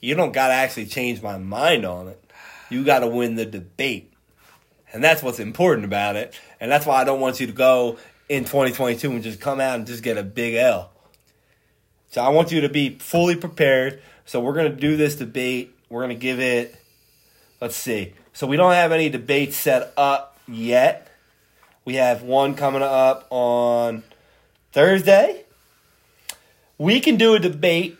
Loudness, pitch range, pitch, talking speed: -20 LUFS, 120-145 Hz, 130 Hz, 185 wpm